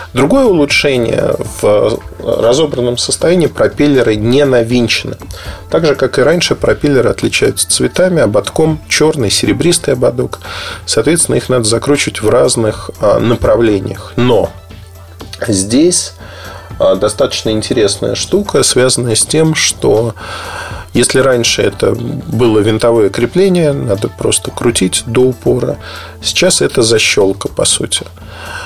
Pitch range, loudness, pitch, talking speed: 100-145 Hz, -11 LUFS, 120 Hz, 110 wpm